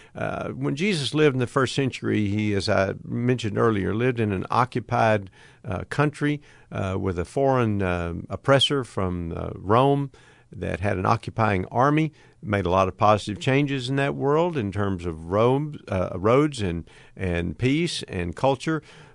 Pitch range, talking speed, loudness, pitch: 95-140 Hz, 165 wpm, -24 LUFS, 115 Hz